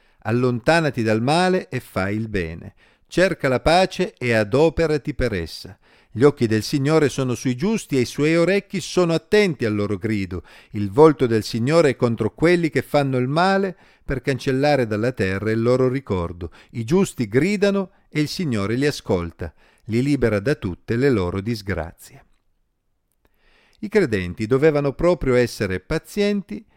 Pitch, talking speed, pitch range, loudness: 130 Hz, 155 wpm, 110-160 Hz, -20 LUFS